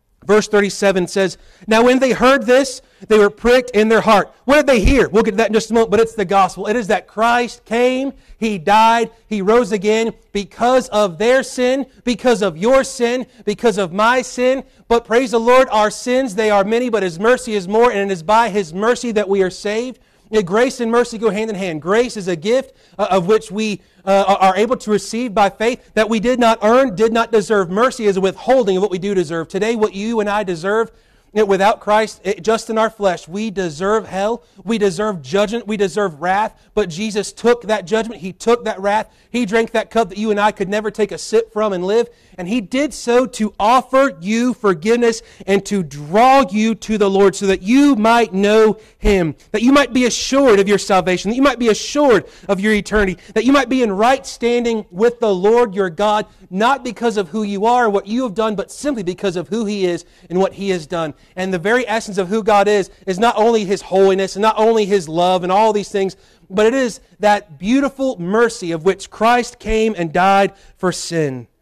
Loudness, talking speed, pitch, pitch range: -16 LUFS, 225 wpm, 215 Hz, 195-235 Hz